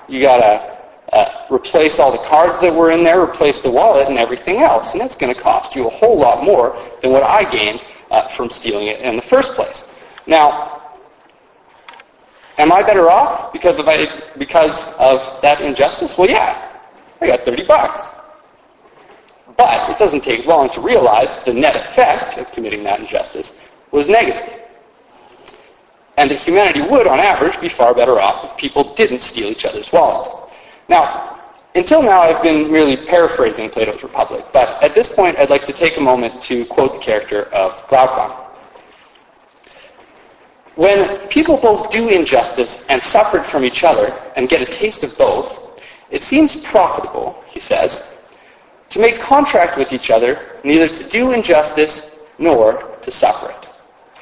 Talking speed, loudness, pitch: 165 wpm, -13 LUFS, 175 Hz